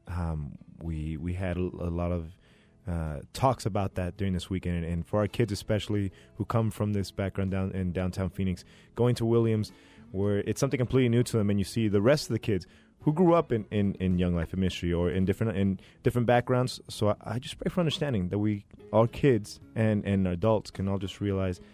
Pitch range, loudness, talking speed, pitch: 90-115 Hz, -29 LUFS, 230 wpm, 100 Hz